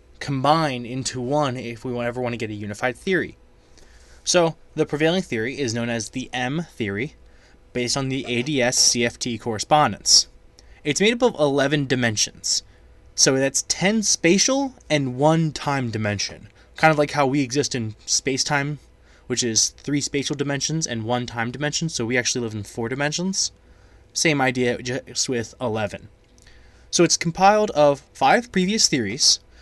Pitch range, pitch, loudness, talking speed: 115-150 Hz, 130 Hz, -21 LUFS, 160 wpm